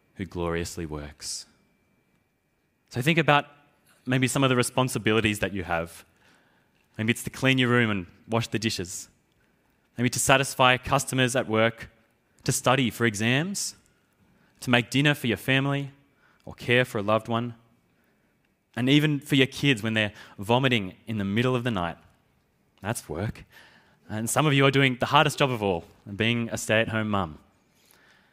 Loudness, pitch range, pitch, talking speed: -25 LUFS, 105-130 Hz, 120 Hz, 165 wpm